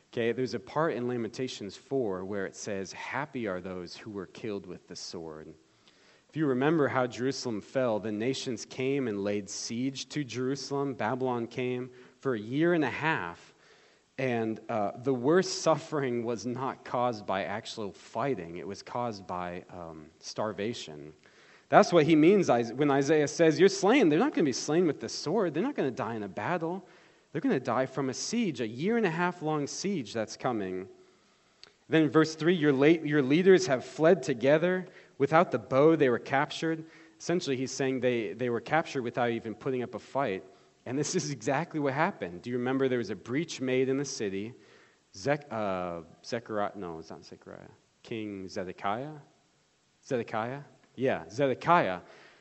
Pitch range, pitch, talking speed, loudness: 110-150 Hz, 130 Hz, 180 wpm, -29 LUFS